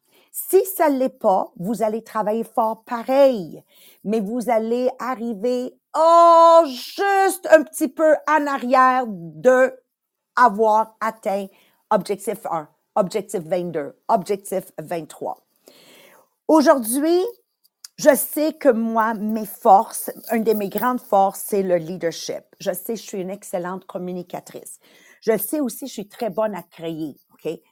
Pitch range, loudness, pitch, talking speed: 200-270 Hz, -20 LUFS, 225 Hz, 140 wpm